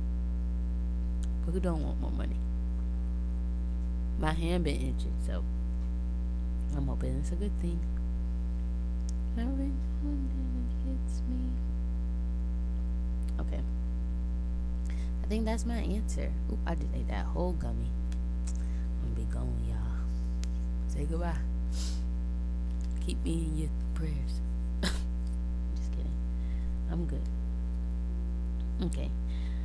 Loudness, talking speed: -34 LUFS, 95 wpm